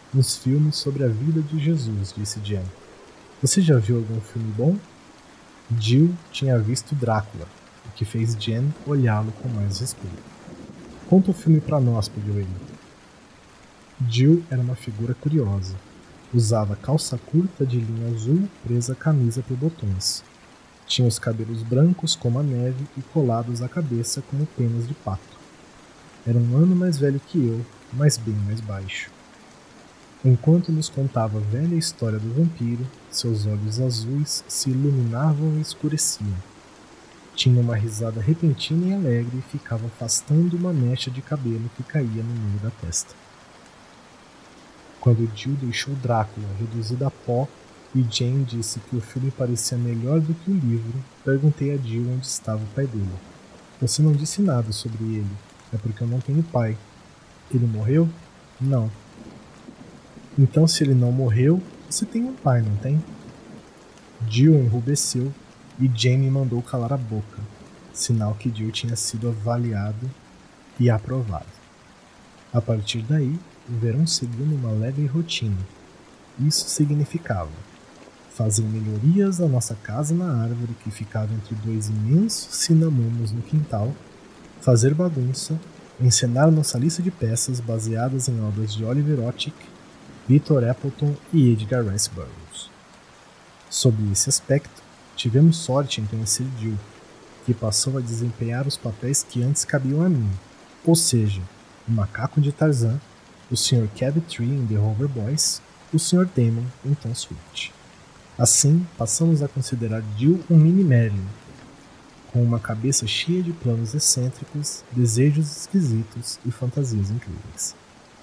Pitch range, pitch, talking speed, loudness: 115-145 Hz, 125 Hz, 145 wpm, -22 LUFS